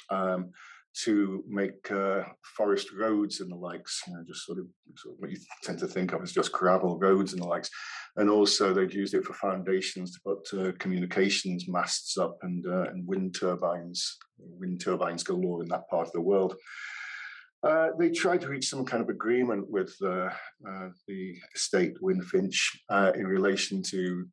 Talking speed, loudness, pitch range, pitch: 190 wpm, -29 LUFS, 90-105 Hz, 95 Hz